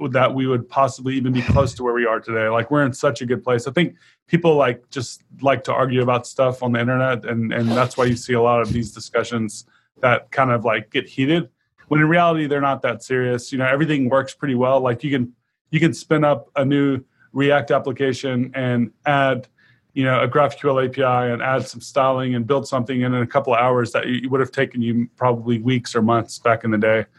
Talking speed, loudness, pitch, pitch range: 235 wpm, -20 LUFS, 130 Hz, 120-135 Hz